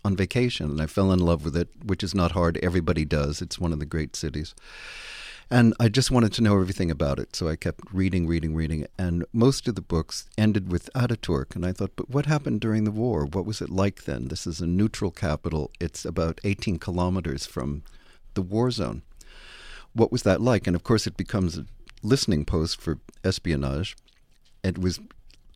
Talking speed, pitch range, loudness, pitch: 205 wpm, 80-110 Hz, -26 LUFS, 90 Hz